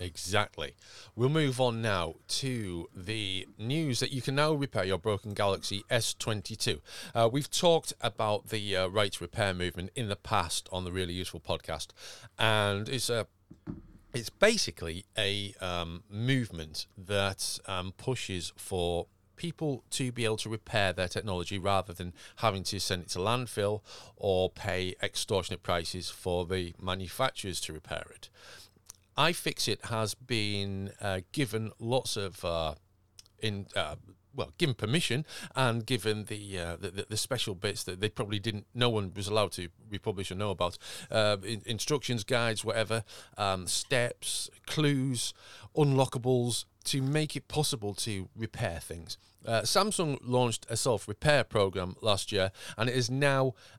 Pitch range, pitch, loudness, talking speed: 95-120 Hz, 105 Hz, -32 LUFS, 155 wpm